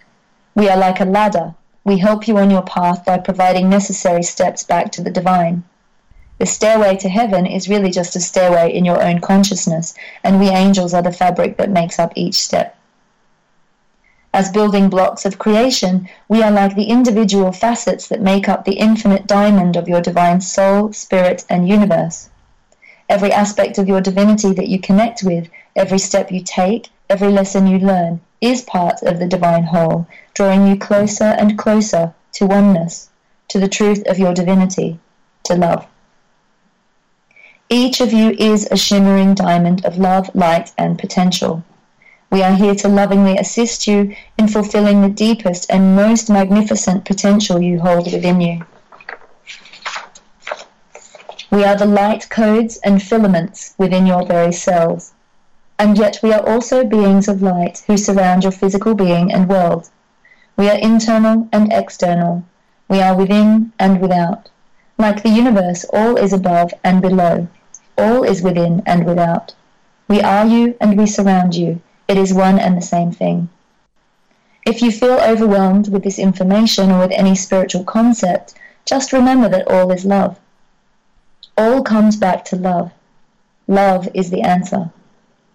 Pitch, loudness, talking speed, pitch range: 195 Hz, -14 LUFS, 160 wpm, 185-210 Hz